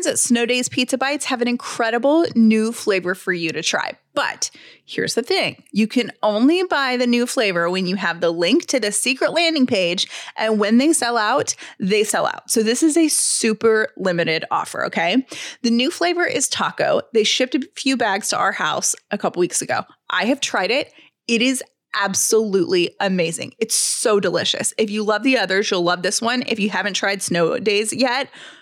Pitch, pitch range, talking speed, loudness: 230 Hz, 200-265 Hz, 200 wpm, -19 LUFS